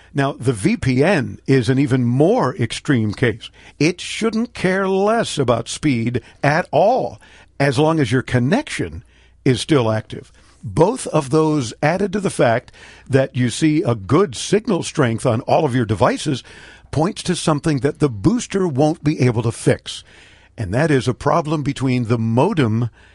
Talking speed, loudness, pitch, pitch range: 165 wpm, -18 LUFS, 135 Hz, 120-155 Hz